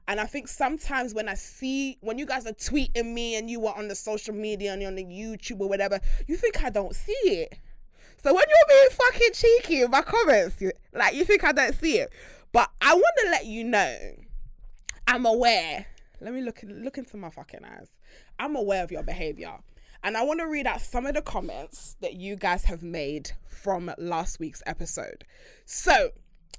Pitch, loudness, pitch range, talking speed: 235 Hz, -25 LUFS, 195-300 Hz, 205 wpm